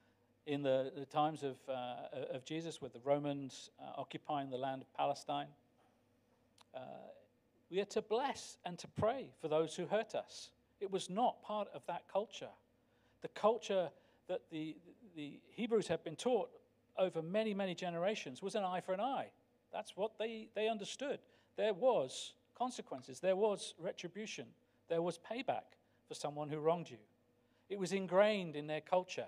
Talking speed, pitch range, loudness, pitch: 165 wpm, 145-210 Hz, -40 LUFS, 175 Hz